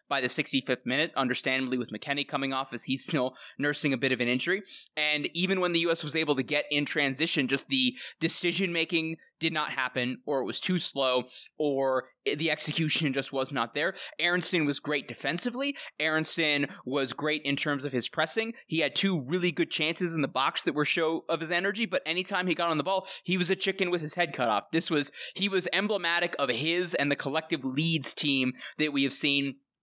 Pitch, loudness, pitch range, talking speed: 155 Hz, -28 LUFS, 140-175 Hz, 215 wpm